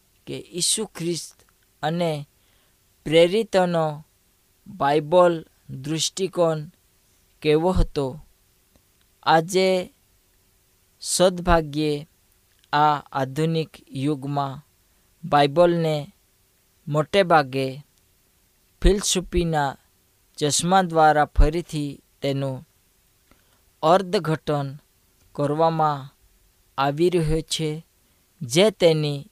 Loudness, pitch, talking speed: -22 LUFS, 150 Hz, 55 wpm